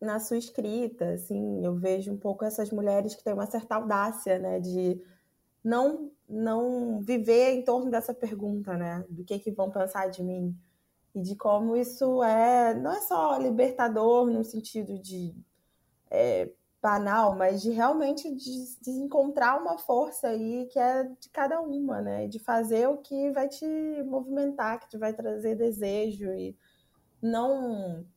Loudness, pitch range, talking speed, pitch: -29 LUFS, 200-255 Hz, 160 wpm, 225 Hz